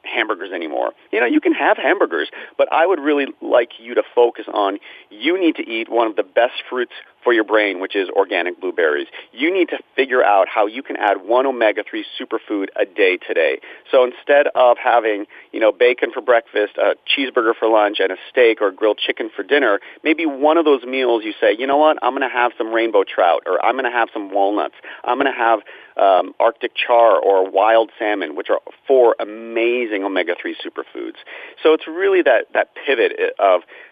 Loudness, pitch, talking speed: -17 LUFS, 330 Hz, 205 wpm